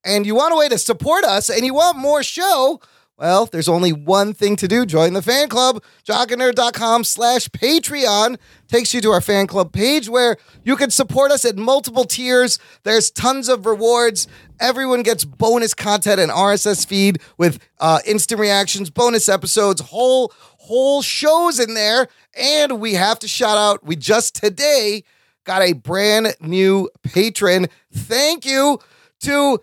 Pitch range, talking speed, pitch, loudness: 200-255 Hz, 165 wpm, 230 Hz, -16 LUFS